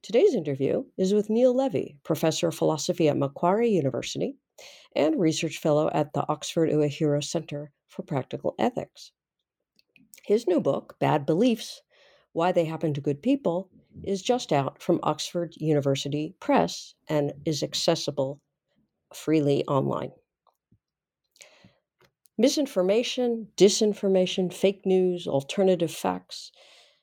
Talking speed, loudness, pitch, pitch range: 115 wpm, -26 LUFS, 170 Hz, 150-205 Hz